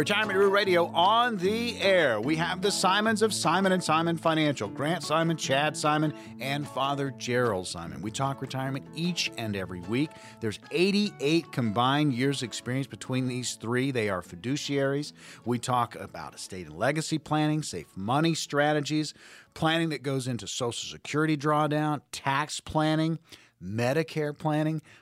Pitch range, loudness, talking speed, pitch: 125-160 Hz, -28 LUFS, 145 wpm, 150 Hz